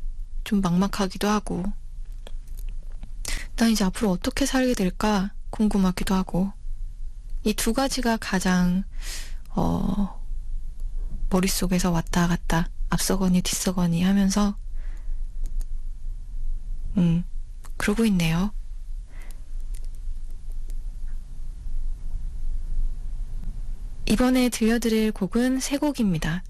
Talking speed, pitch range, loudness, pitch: 175 characters per minute, 170-215 Hz, -24 LUFS, 190 Hz